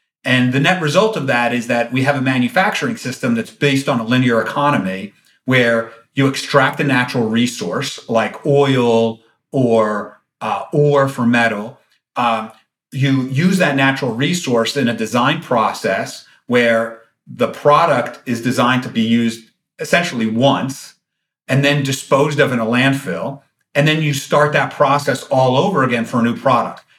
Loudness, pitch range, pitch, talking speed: -16 LUFS, 115-140 Hz, 130 Hz, 160 wpm